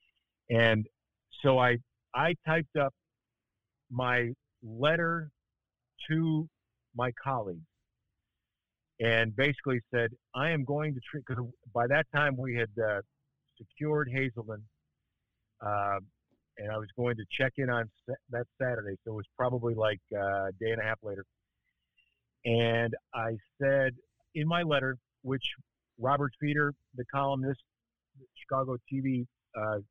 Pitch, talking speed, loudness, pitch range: 120 Hz, 135 wpm, -31 LUFS, 110-140 Hz